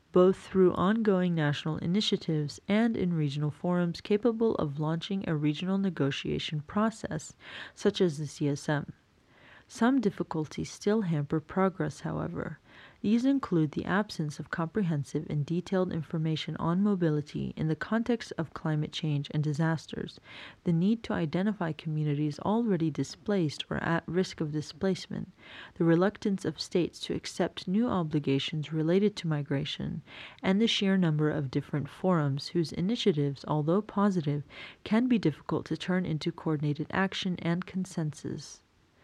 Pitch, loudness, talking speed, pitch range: 170 Hz, -30 LUFS, 135 wpm, 155-195 Hz